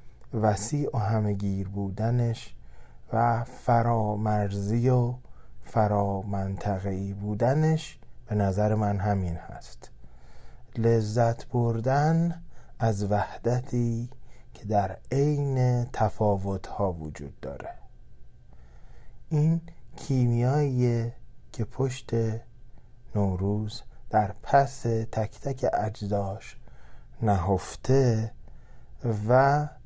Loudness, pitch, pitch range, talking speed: -27 LUFS, 110 Hz, 100-120 Hz, 75 wpm